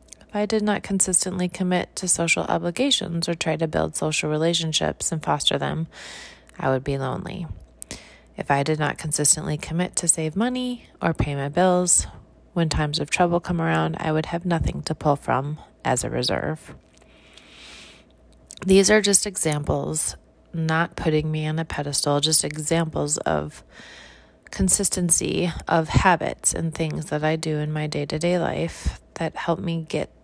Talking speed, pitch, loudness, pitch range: 165 wpm, 160 Hz, -22 LUFS, 145-180 Hz